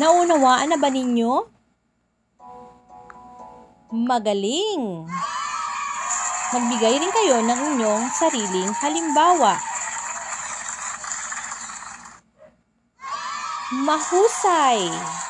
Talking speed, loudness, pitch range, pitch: 55 wpm, -21 LUFS, 205-315 Hz, 250 Hz